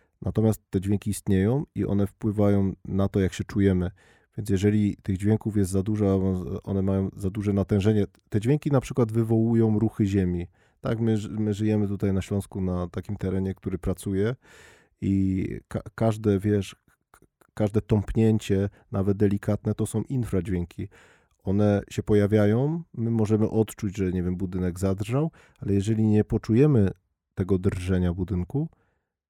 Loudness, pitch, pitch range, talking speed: -26 LUFS, 100 Hz, 95-110 Hz, 145 wpm